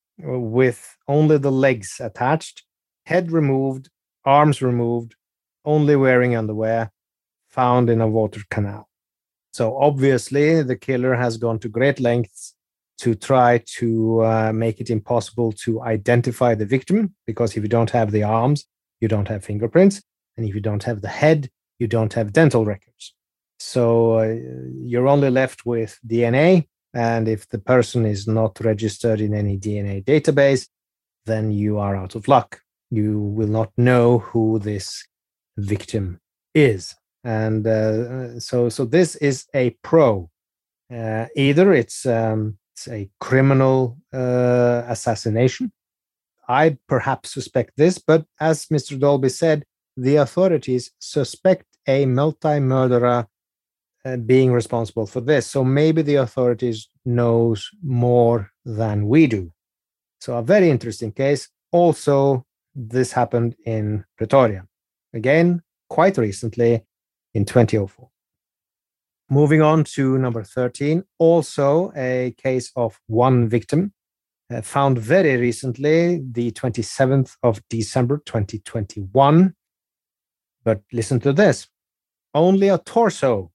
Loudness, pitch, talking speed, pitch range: -19 LUFS, 120 Hz, 130 wpm, 110-140 Hz